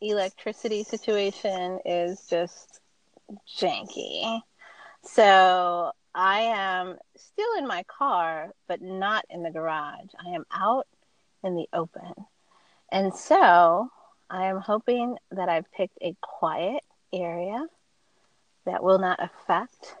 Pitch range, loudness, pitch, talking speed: 175-215 Hz, -26 LUFS, 190 Hz, 115 wpm